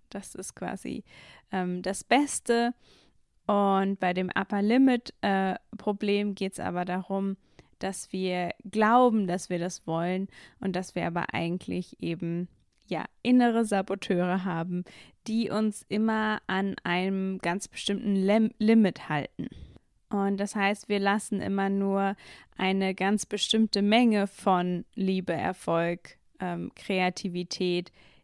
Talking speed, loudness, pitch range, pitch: 130 wpm, -28 LUFS, 180-210 Hz, 195 Hz